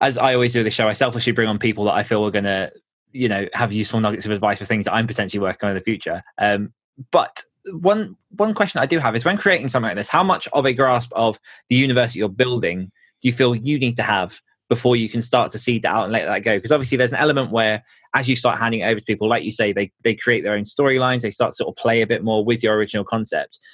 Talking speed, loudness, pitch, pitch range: 290 wpm, -19 LUFS, 115 Hz, 105-130 Hz